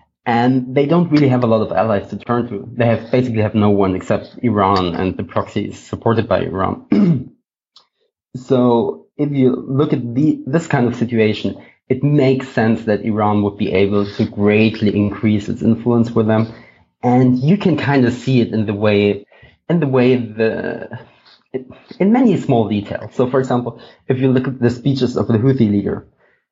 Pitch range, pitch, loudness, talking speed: 105-130 Hz, 120 Hz, -16 LUFS, 185 wpm